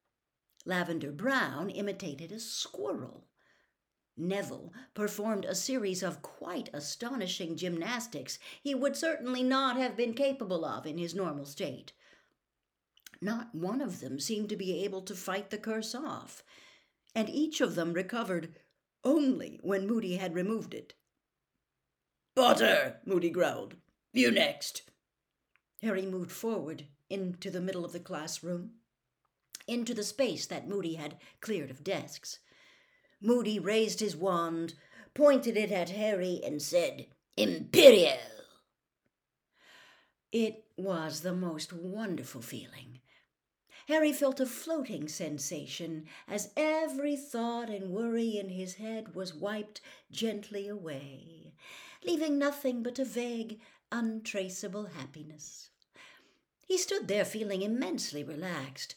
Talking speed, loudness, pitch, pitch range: 120 wpm, -32 LUFS, 205 Hz, 175-240 Hz